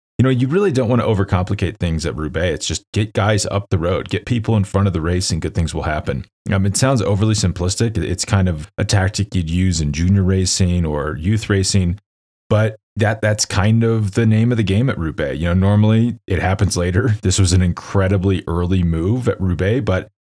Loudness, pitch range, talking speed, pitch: -18 LUFS, 90-110 Hz, 220 wpm, 95 Hz